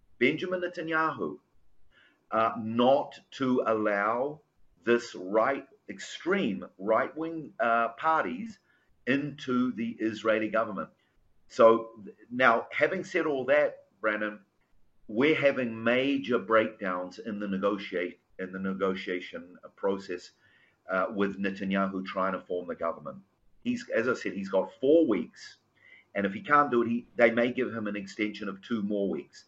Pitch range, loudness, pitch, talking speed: 100-135 Hz, -29 LUFS, 115 Hz, 135 wpm